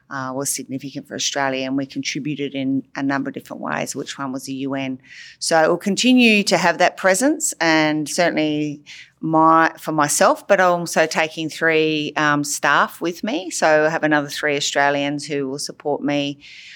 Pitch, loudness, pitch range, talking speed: 150 Hz, -19 LUFS, 140-170 Hz, 180 wpm